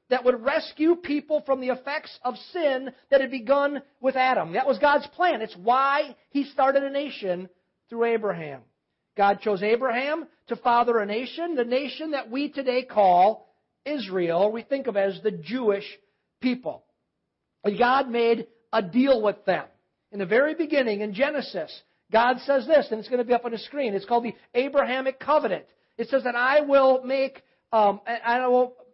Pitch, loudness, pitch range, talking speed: 250 Hz, -24 LUFS, 225-275 Hz, 185 wpm